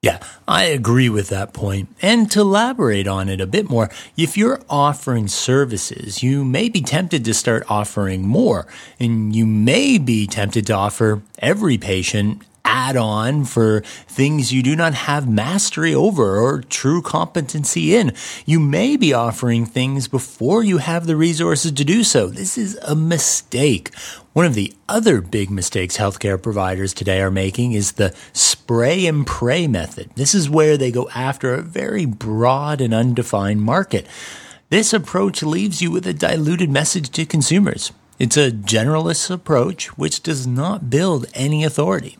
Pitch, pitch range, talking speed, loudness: 135 Hz, 110-165 Hz, 165 wpm, -17 LUFS